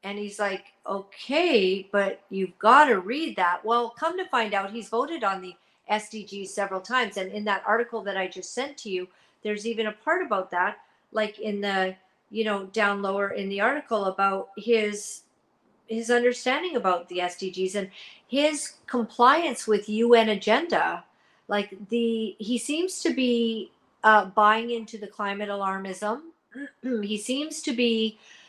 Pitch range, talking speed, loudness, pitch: 195-240 Hz, 160 wpm, -26 LUFS, 215 Hz